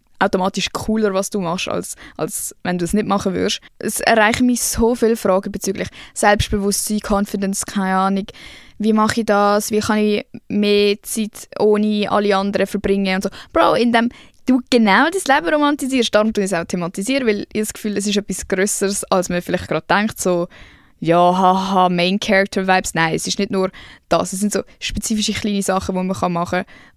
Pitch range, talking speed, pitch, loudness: 190-215 Hz, 190 wpm, 205 Hz, -18 LUFS